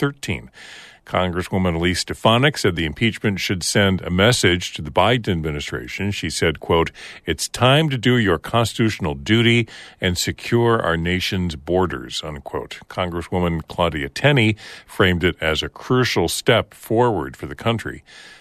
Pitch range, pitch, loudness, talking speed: 85-115 Hz, 90 Hz, -20 LUFS, 145 wpm